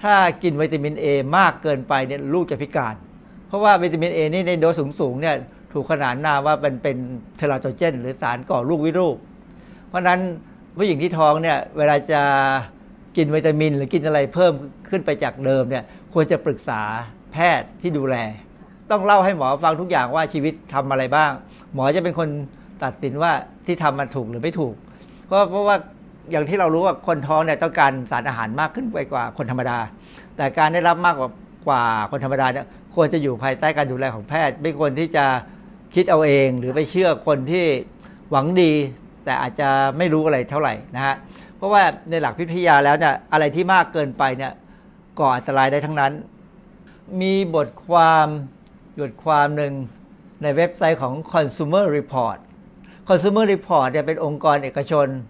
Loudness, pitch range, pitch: -20 LUFS, 135-180 Hz, 155 Hz